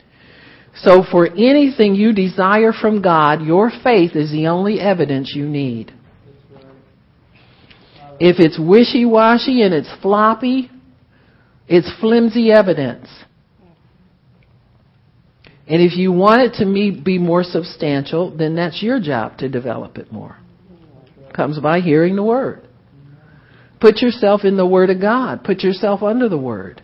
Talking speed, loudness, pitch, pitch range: 130 wpm, -14 LUFS, 180 Hz, 145-215 Hz